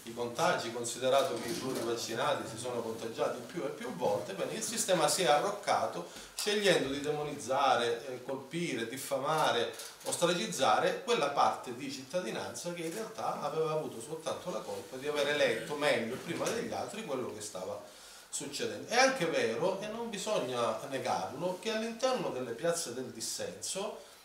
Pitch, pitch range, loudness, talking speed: 145 Hz, 120-180 Hz, -33 LUFS, 155 wpm